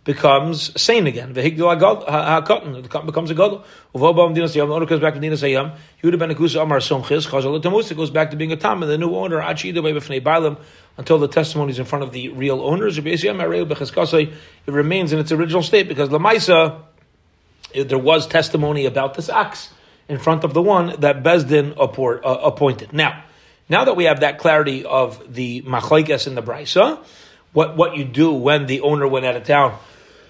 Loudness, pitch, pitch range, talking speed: -18 LUFS, 155 Hz, 140-165 Hz, 155 wpm